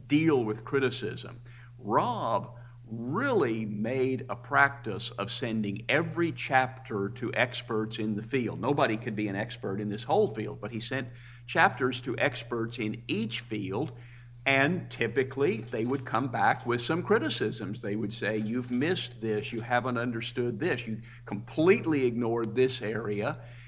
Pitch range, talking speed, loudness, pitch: 110-130 Hz, 150 wpm, -30 LUFS, 120 Hz